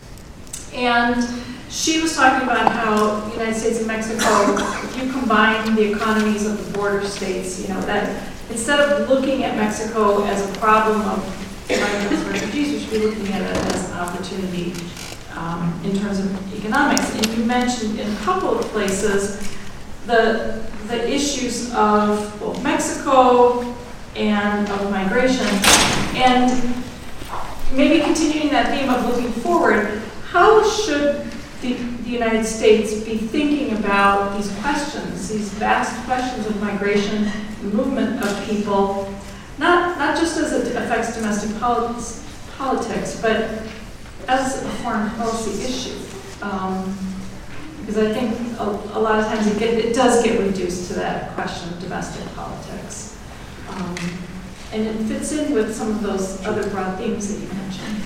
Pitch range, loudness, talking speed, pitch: 205-245 Hz, -20 LUFS, 150 wpm, 220 Hz